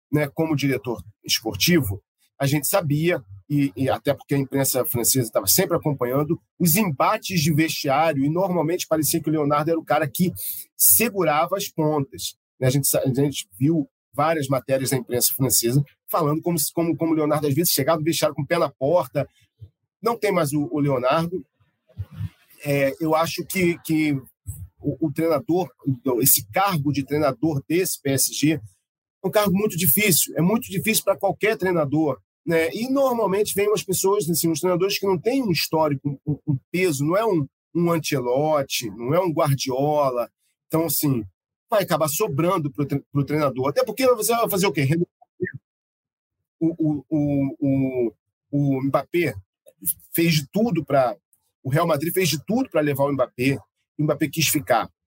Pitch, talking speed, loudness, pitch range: 155 Hz, 165 wpm, -22 LUFS, 135-170 Hz